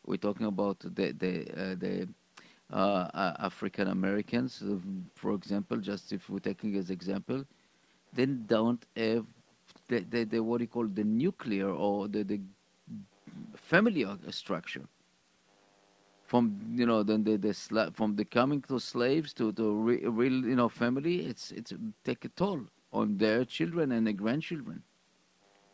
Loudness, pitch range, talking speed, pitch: -32 LUFS, 100-120 Hz, 145 wpm, 110 Hz